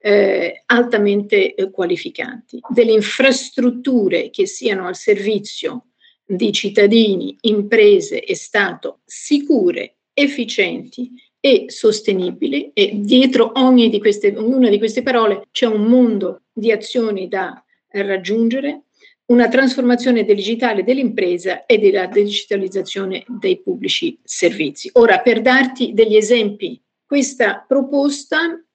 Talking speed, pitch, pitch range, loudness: 110 wpm, 245 Hz, 210-280 Hz, -16 LUFS